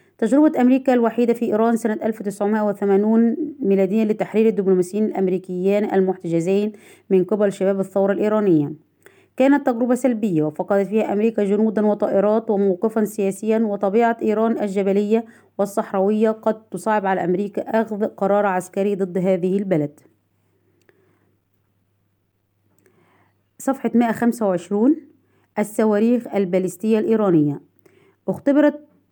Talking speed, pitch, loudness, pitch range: 95 wpm, 205 Hz, -20 LUFS, 190-225 Hz